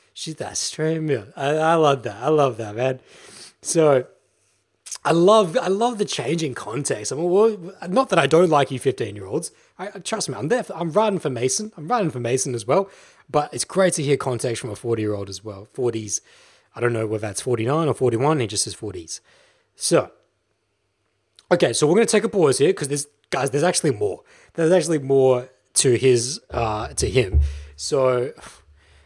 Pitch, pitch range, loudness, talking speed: 135 Hz, 115-170 Hz, -21 LUFS, 190 wpm